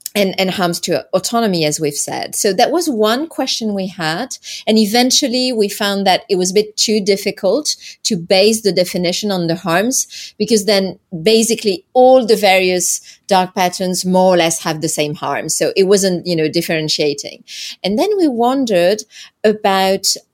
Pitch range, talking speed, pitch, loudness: 180-220 Hz, 175 wpm, 195 Hz, -15 LUFS